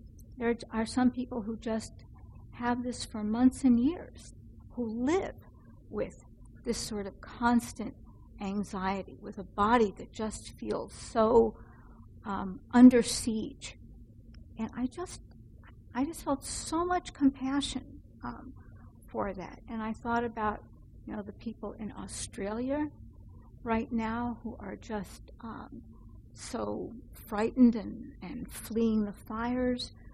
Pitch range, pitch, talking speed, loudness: 220-250 Hz, 235 Hz, 130 wpm, -31 LUFS